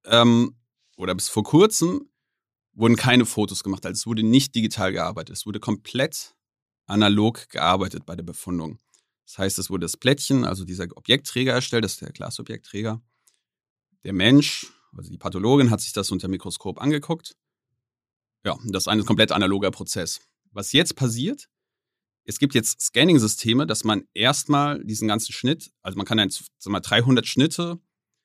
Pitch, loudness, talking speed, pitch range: 110 Hz, -22 LUFS, 160 wpm, 95-130 Hz